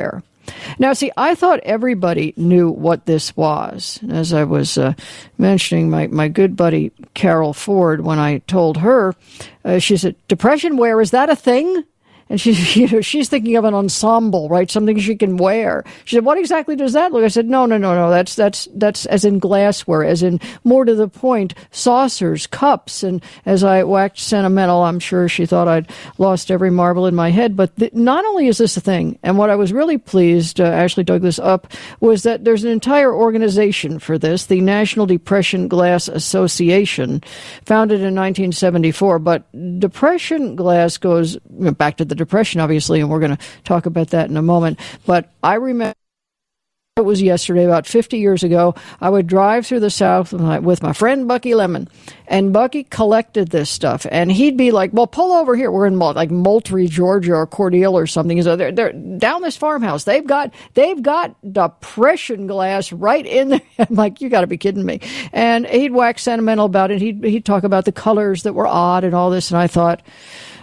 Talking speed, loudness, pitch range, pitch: 205 wpm, -15 LUFS, 175-230 Hz, 195 Hz